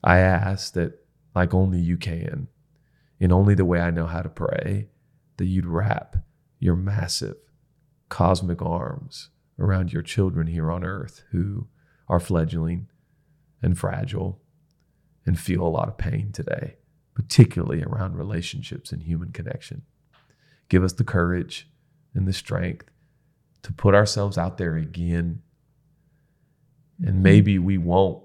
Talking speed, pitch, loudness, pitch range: 135 wpm, 110 Hz, -24 LUFS, 90-145 Hz